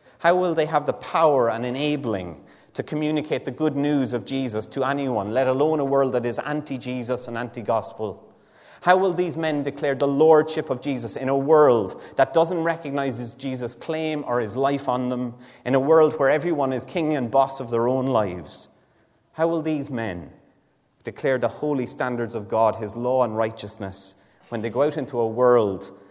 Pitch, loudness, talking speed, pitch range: 130 Hz, -23 LUFS, 195 wpm, 115-150 Hz